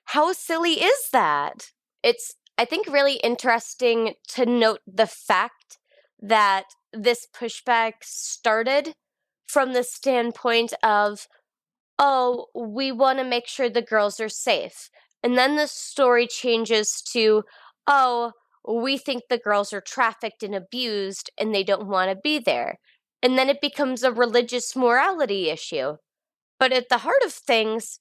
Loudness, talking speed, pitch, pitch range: -22 LUFS, 145 wpm, 245 Hz, 225-275 Hz